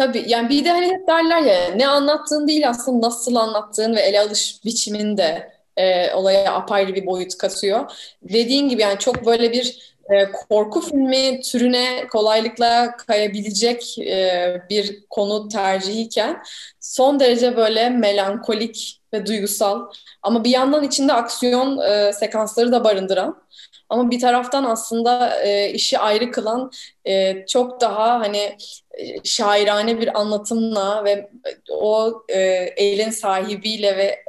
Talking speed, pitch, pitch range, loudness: 120 wpm, 225 Hz, 205-250 Hz, -18 LUFS